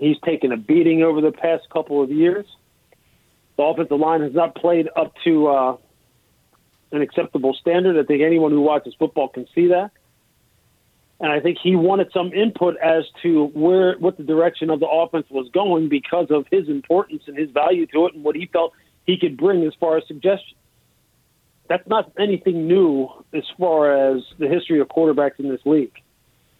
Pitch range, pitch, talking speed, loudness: 150-175 Hz, 160 Hz, 185 wpm, -19 LUFS